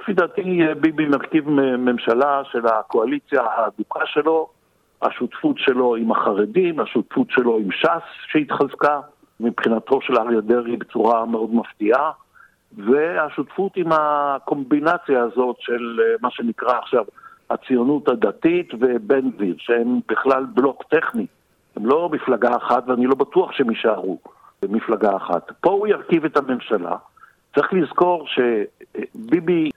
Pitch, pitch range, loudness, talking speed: 140 Hz, 120-160 Hz, -20 LUFS, 120 wpm